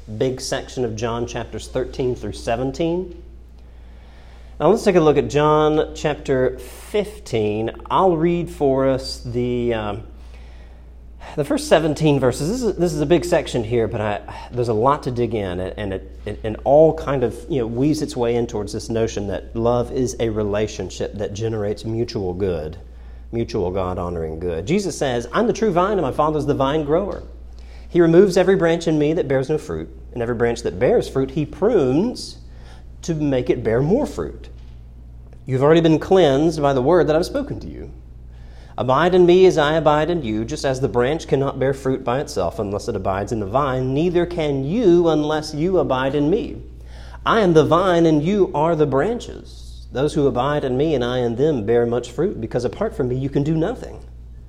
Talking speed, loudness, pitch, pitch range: 200 wpm, -19 LUFS, 125 Hz, 100-155 Hz